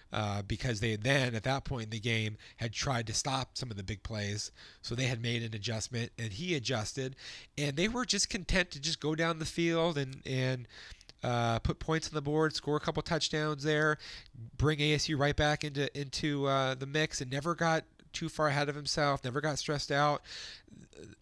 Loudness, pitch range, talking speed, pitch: -33 LUFS, 120-155 Hz, 205 wpm, 140 Hz